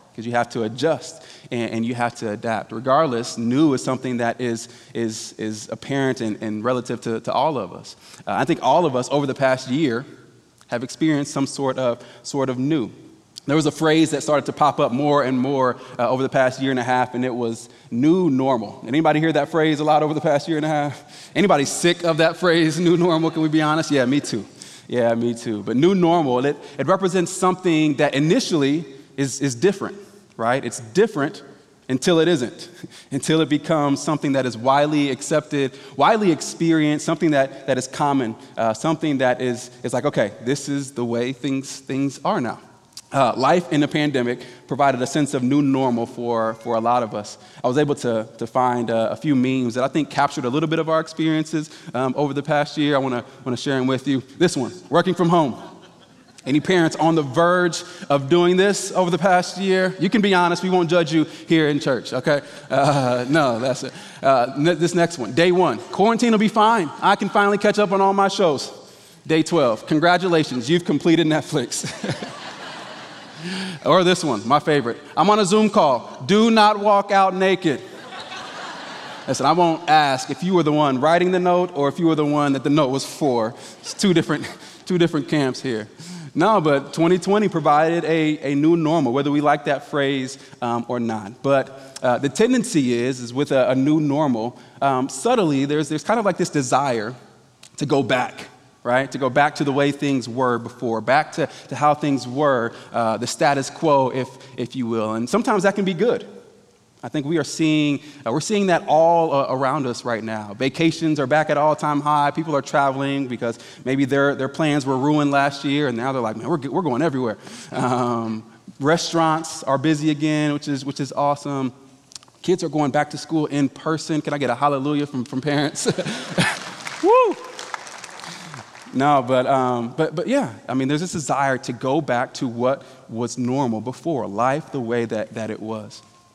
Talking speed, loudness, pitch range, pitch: 205 wpm, -20 LUFS, 125-160 Hz, 145 Hz